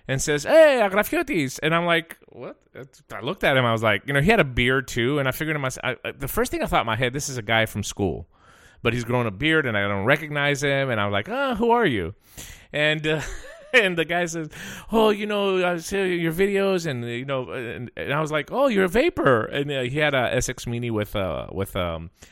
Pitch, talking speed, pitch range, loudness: 140 Hz, 260 wpm, 120-175 Hz, -22 LUFS